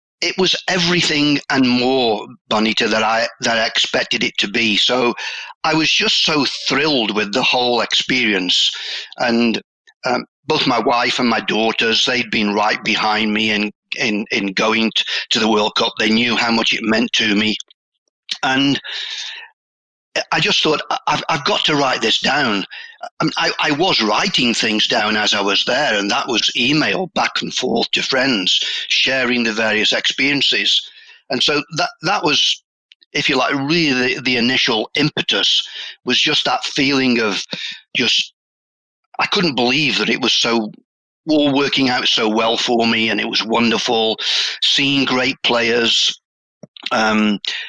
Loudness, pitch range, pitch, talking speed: -16 LUFS, 110-140 Hz, 120 Hz, 165 wpm